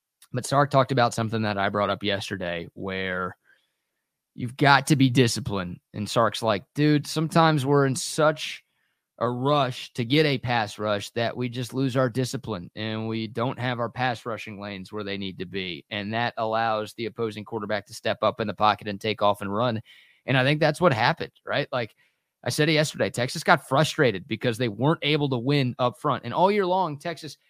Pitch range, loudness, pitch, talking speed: 105-140 Hz, -25 LUFS, 120 Hz, 205 wpm